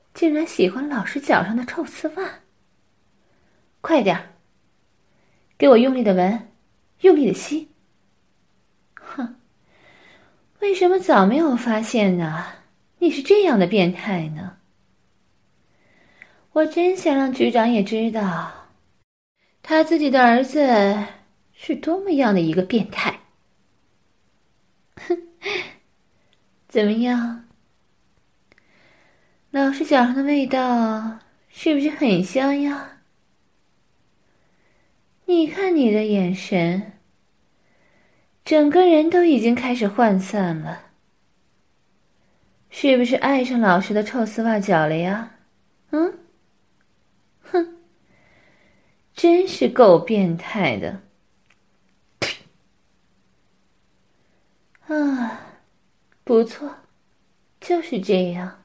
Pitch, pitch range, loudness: 250 Hz, 210-315 Hz, -20 LUFS